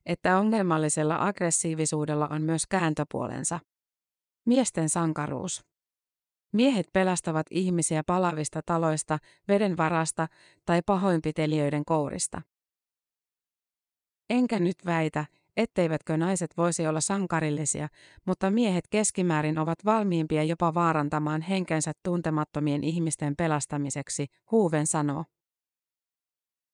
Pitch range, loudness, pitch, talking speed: 155-180 Hz, -27 LUFS, 160 Hz, 85 wpm